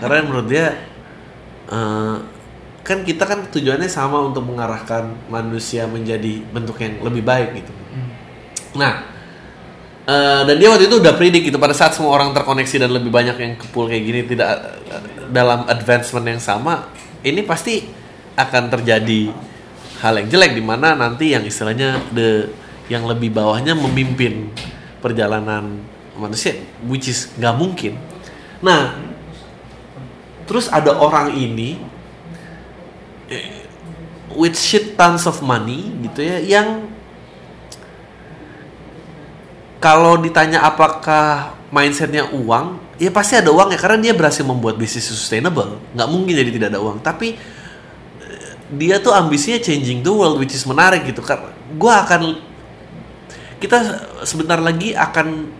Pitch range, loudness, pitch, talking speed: 115-160 Hz, -15 LUFS, 130 Hz, 130 wpm